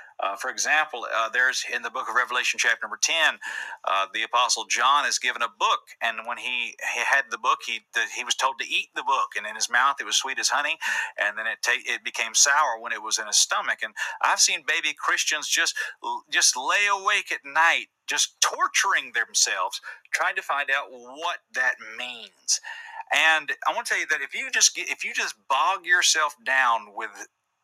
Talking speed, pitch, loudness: 210 wpm, 180 Hz, -23 LUFS